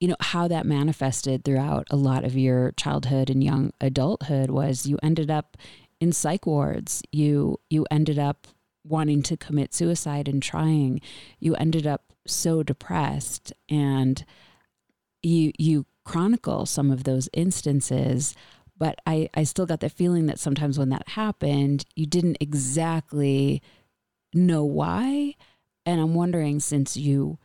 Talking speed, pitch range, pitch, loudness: 145 wpm, 135-160 Hz, 145 Hz, -24 LUFS